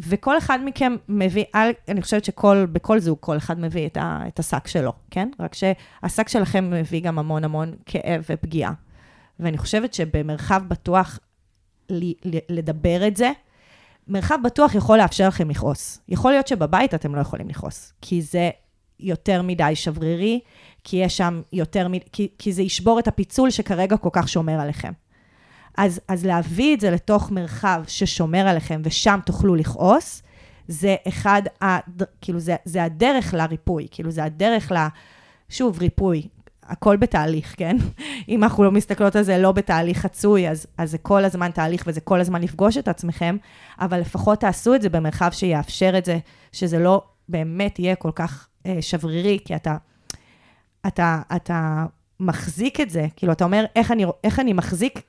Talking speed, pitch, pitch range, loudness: 160 wpm, 180 Hz, 165-200 Hz, -21 LUFS